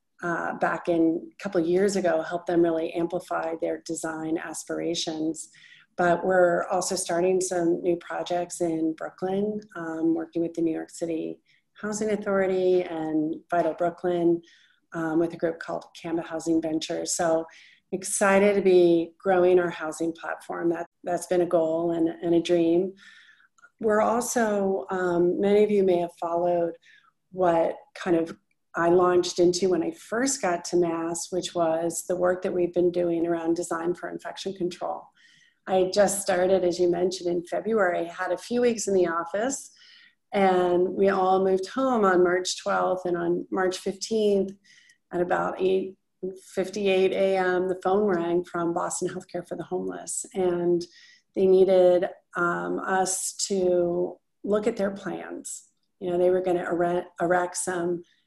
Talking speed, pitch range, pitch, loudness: 160 wpm, 170-190 Hz, 180 Hz, -25 LUFS